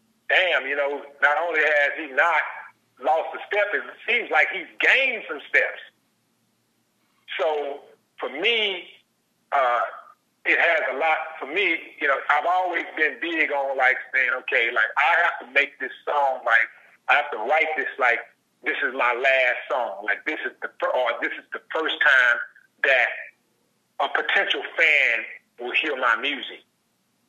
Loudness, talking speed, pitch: -22 LUFS, 165 wpm, 200 Hz